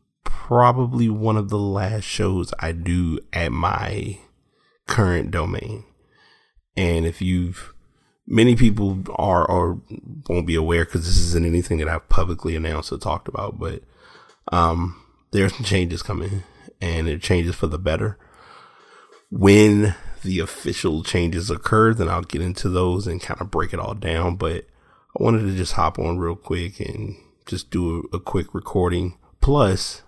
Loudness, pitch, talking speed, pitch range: -22 LUFS, 90 Hz, 160 wpm, 85-105 Hz